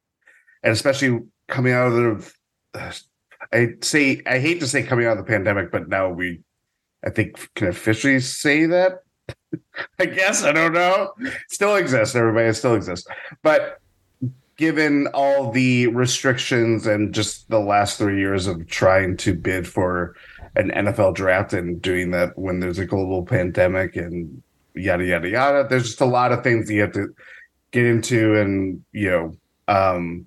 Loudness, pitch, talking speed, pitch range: -20 LUFS, 110 Hz, 165 wpm, 95-130 Hz